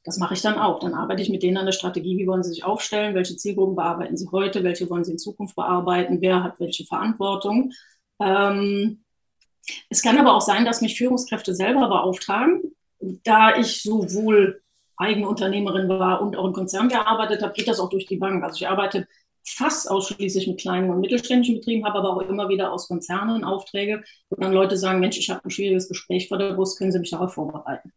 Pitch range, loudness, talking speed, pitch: 185-210 Hz, -22 LUFS, 210 wpm, 195 Hz